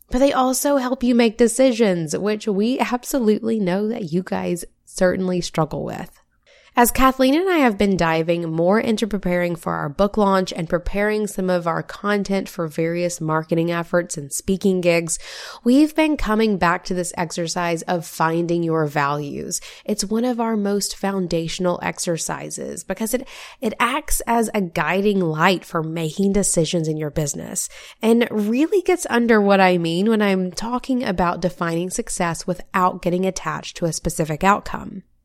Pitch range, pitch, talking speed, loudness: 170-225 Hz, 190 Hz, 165 wpm, -20 LUFS